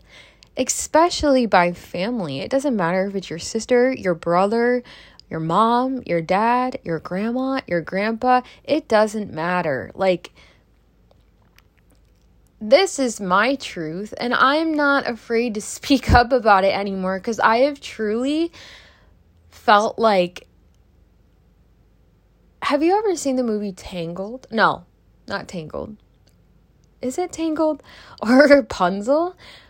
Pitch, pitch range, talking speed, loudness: 225 Hz, 185-265 Hz, 120 wpm, -20 LUFS